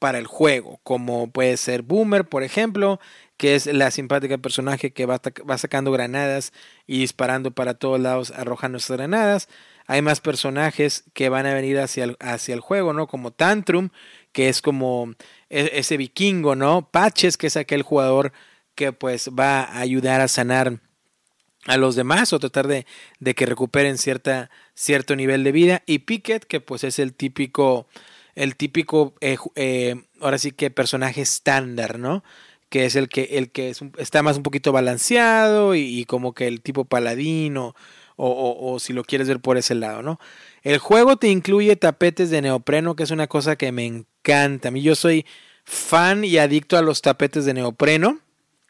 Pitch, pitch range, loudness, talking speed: 140 Hz, 130-155 Hz, -20 LUFS, 180 wpm